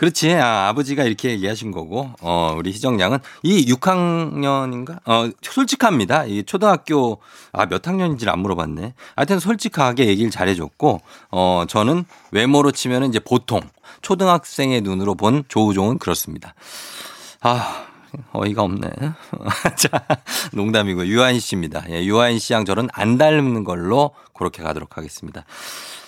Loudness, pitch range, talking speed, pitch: -19 LUFS, 95-145 Hz, 320 characters per minute, 120 Hz